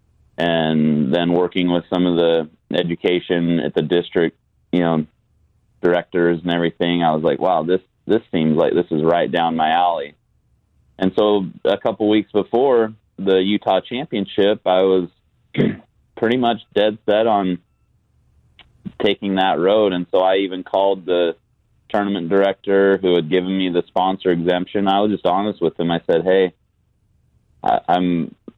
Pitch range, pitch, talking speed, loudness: 85-95 Hz, 90 Hz, 155 wpm, -18 LUFS